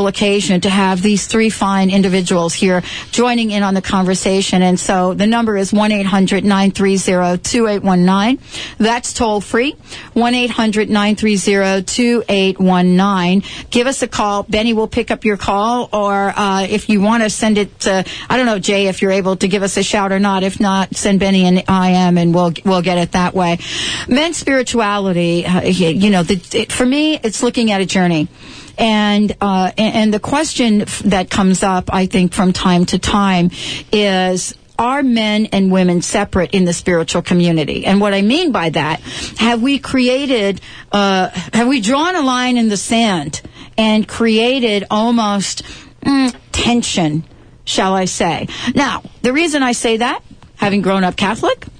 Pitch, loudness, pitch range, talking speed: 200 Hz, -14 LUFS, 185-225 Hz, 190 wpm